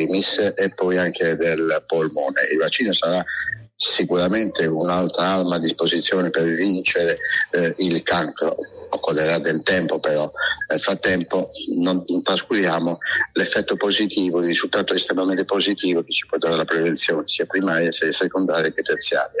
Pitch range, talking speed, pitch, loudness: 85-95 Hz, 135 wpm, 90 Hz, -20 LUFS